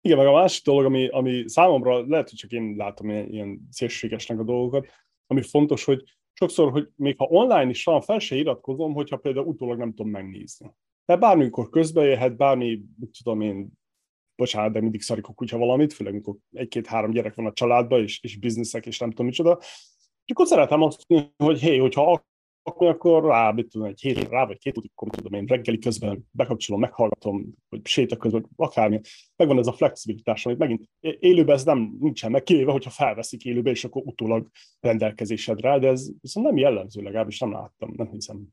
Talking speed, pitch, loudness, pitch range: 200 wpm, 120 Hz, -23 LUFS, 110-140 Hz